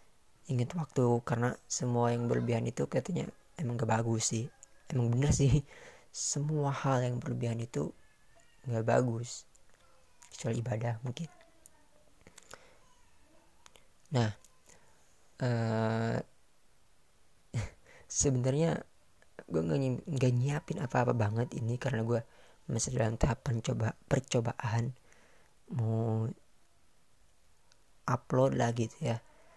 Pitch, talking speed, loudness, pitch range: 120 Hz, 95 wpm, -33 LUFS, 115-130 Hz